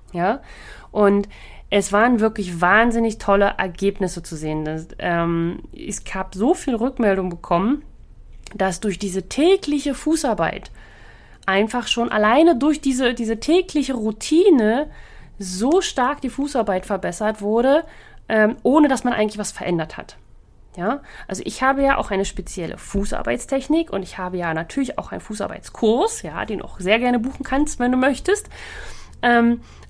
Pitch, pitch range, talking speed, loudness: 220 Hz, 190-270 Hz, 150 wpm, -20 LUFS